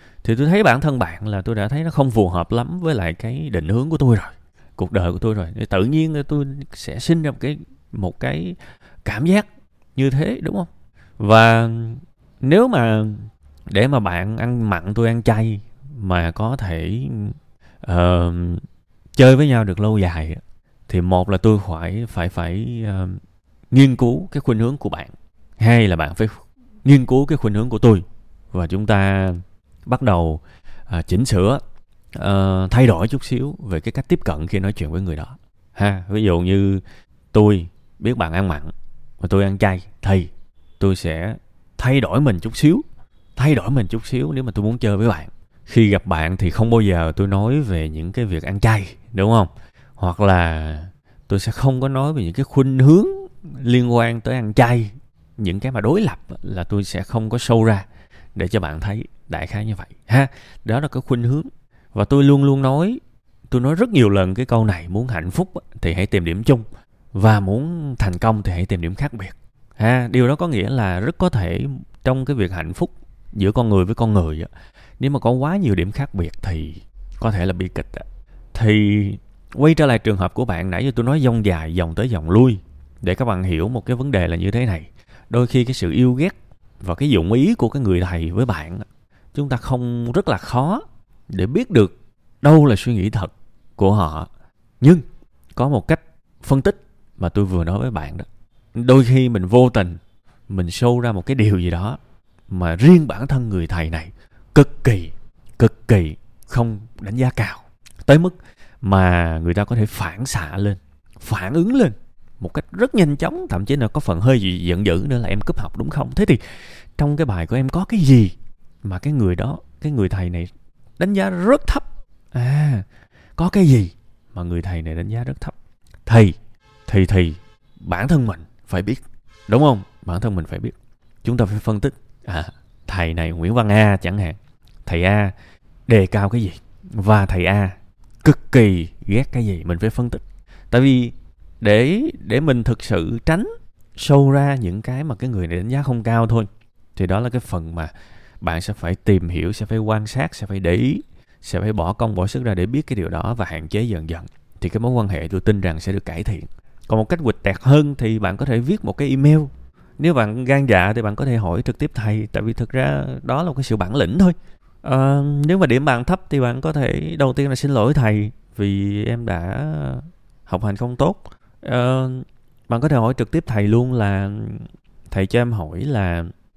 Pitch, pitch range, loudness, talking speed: 110 Hz, 95-130 Hz, -18 LUFS, 215 wpm